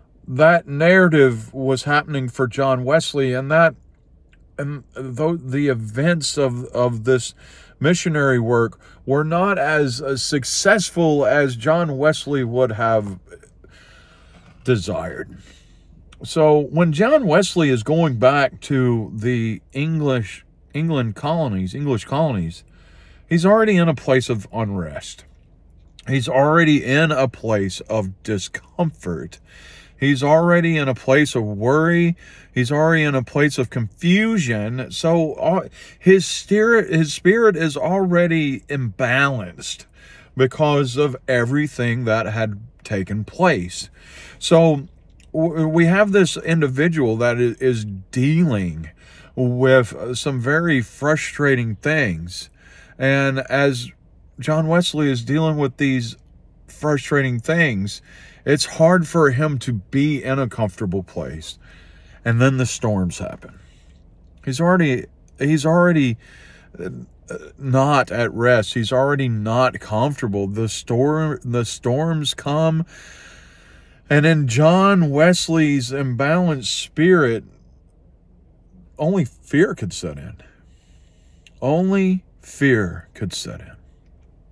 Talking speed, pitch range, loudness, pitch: 110 wpm, 110-155 Hz, -18 LUFS, 135 Hz